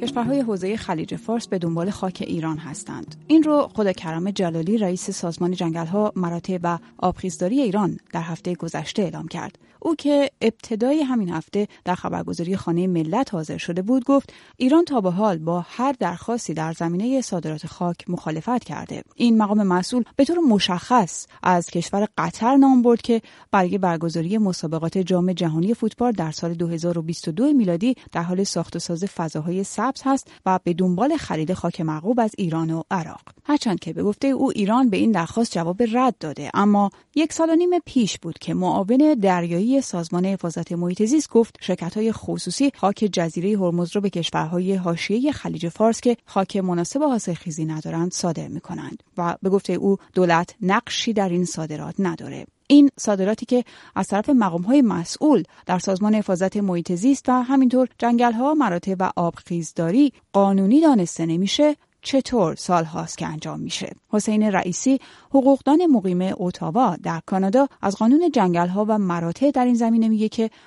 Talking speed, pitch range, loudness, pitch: 165 wpm, 175-240 Hz, -21 LUFS, 195 Hz